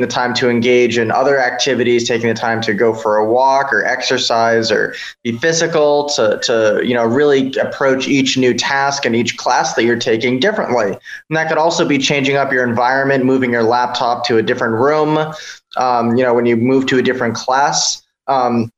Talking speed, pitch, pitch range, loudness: 200 wpm, 125 Hz, 120-140 Hz, -14 LUFS